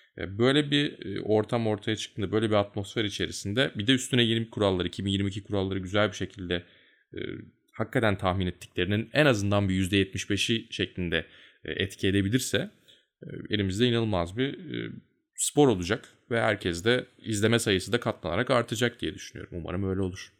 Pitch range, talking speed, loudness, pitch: 95-115 Hz, 140 wpm, -28 LUFS, 105 Hz